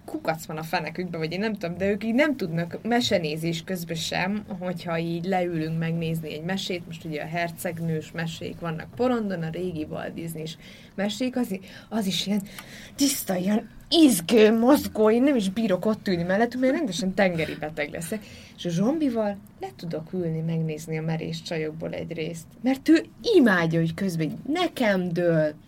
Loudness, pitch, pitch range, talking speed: -25 LUFS, 180 Hz, 165-220 Hz, 170 wpm